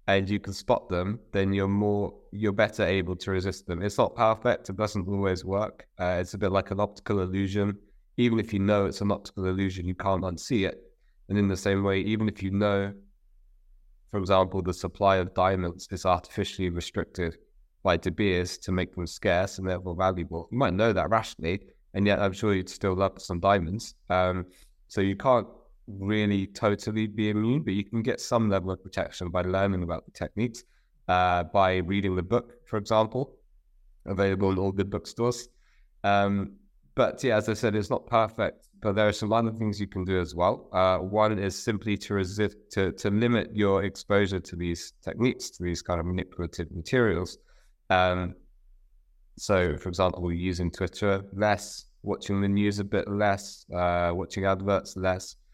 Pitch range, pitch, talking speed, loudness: 90-105 Hz, 95 Hz, 185 wpm, -28 LUFS